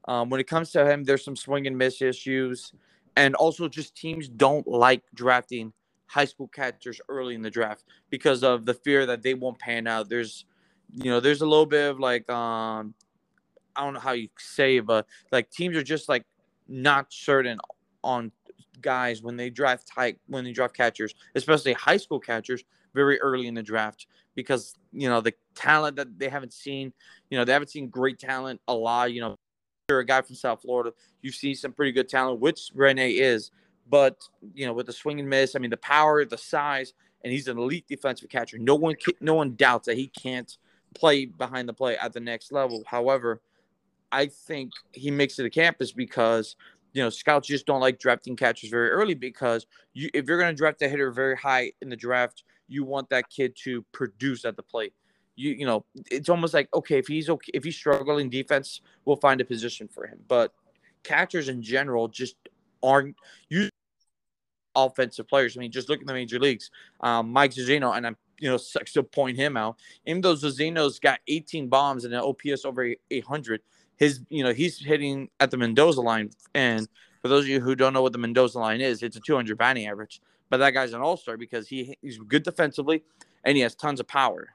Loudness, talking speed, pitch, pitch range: -25 LUFS, 210 wpm, 130 Hz, 120-140 Hz